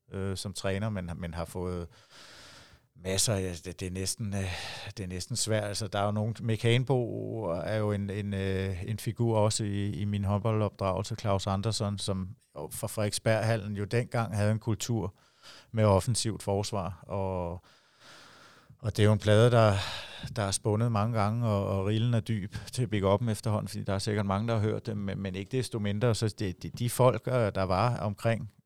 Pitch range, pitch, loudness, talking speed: 95-115 Hz, 105 Hz, -30 LUFS, 180 wpm